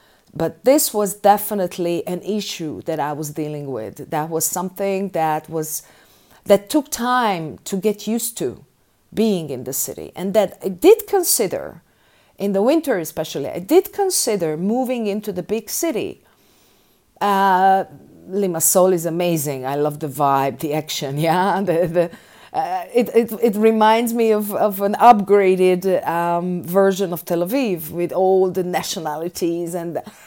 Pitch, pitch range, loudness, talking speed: 190 Hz, 165-215 Hz, -19 LUFS, 155 wpm